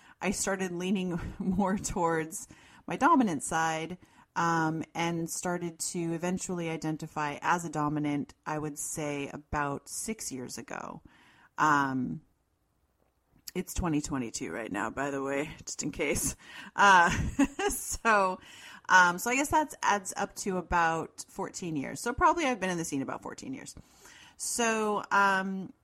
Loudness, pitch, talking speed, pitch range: -30 LUFS, 170 Hz, 145 wpm, 150-195 Hz